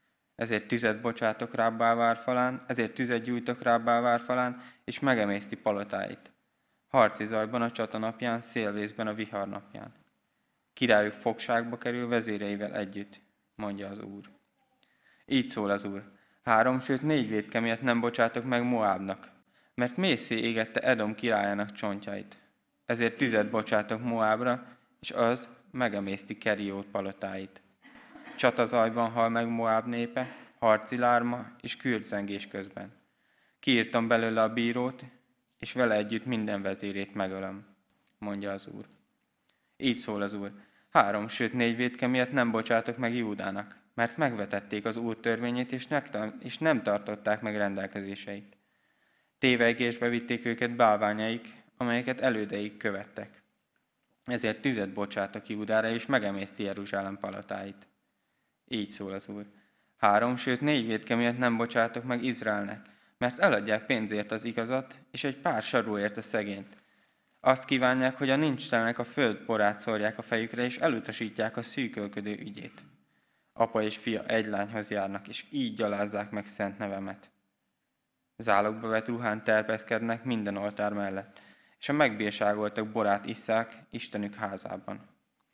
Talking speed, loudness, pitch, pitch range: 130 wpm, -30 LUFS, 110 Hz, 105-120 Hz